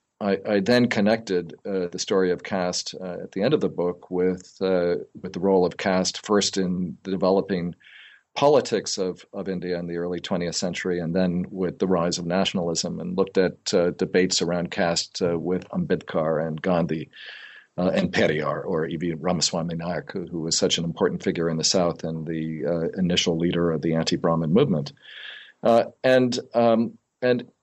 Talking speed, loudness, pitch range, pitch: 185 wpm, -24 LUFS, 85-95 Hz, 90 Hz